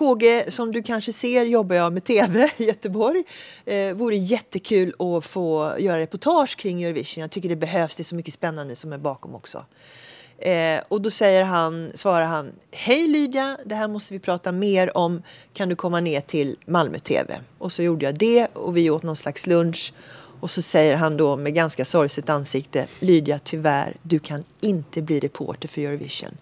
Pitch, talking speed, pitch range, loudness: 175 Hz, 185 wpm, 155-210 Hz, -22 LUFS